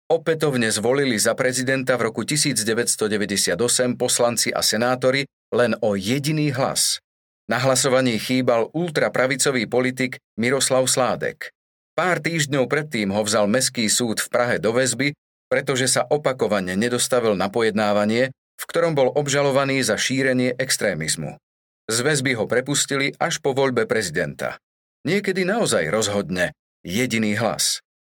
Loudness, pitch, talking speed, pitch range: -21 LUFS, 130 Hz, 125 wpm, 115-140 Hz